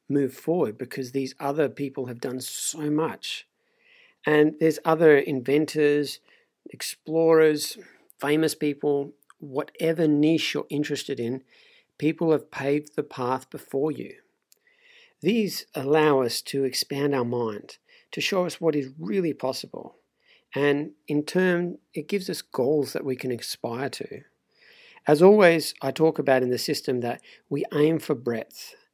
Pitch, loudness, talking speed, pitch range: 150 Hz, -25 LUFS, 140 wpm, 135-160 Hz